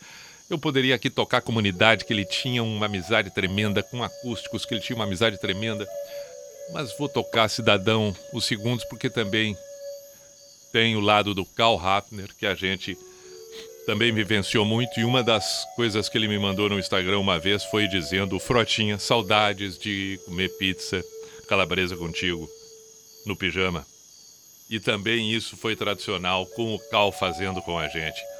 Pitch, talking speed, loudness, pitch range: 110 Hz, 155 wpm, -24 LUFS, 95-120 Hz